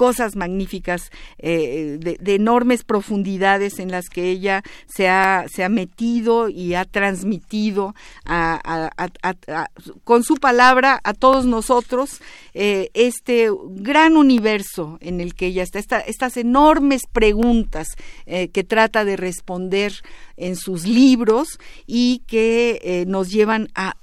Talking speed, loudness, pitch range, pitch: 140 wpm, -18 LUFS, 185-235 Hz, 205 Hz